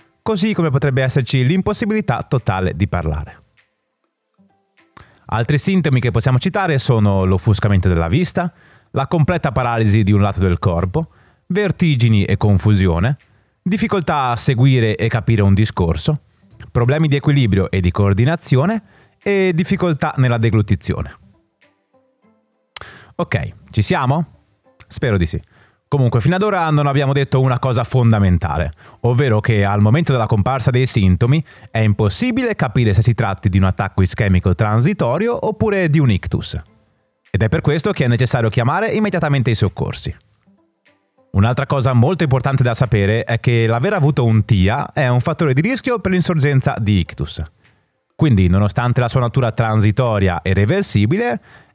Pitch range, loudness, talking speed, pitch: 105-155 Hz, -16 LUFS, 145 wpm, 125 Hz